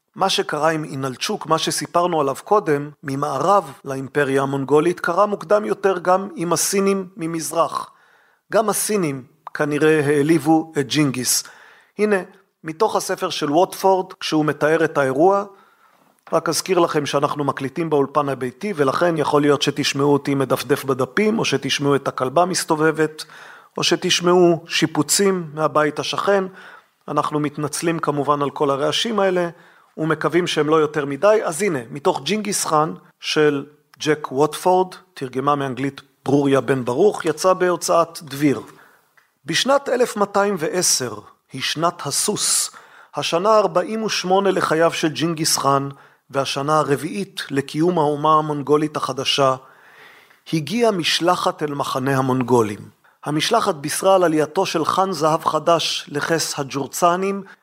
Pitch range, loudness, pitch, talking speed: 145-180 Hz, -19 LUFS, 155 Hz, 120 wpm